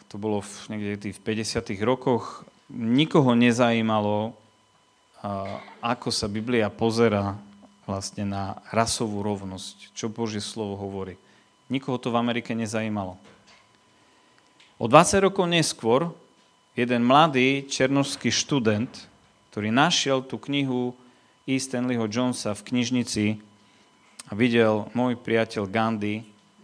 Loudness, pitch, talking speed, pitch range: -24 LUFS, 115 Hz, 110 wpm, 105-125 Hz